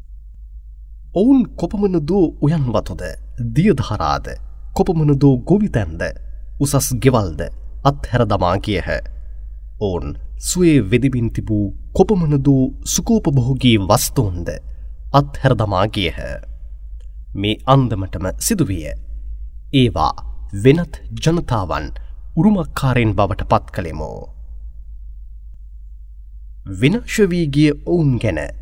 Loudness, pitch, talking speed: -17 LUFS, 105 Hz, 70 wpm